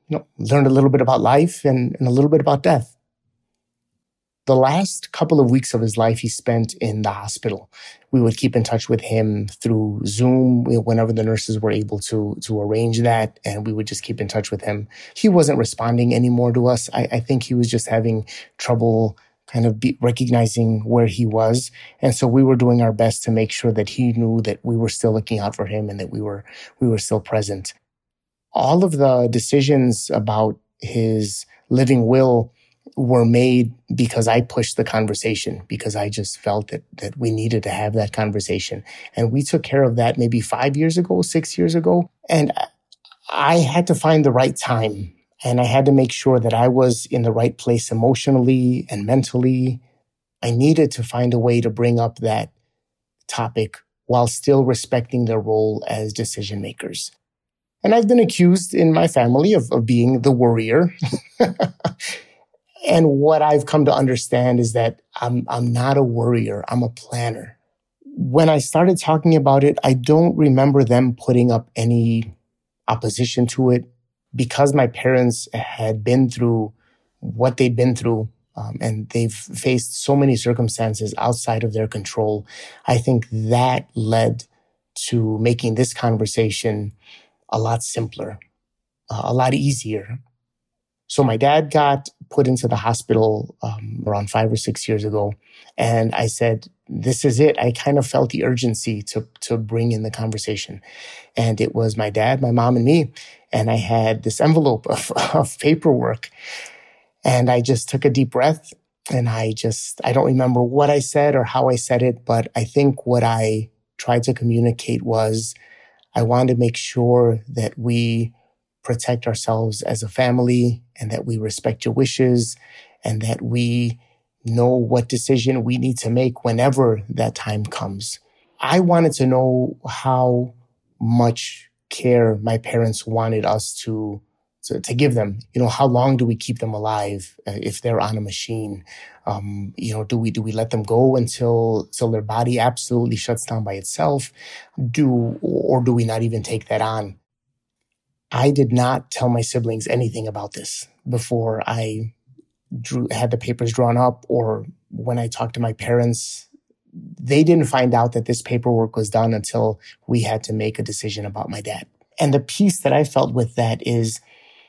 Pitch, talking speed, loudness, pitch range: 120 Hz, 180 wpm, -19 LUFS, 110-130 Hz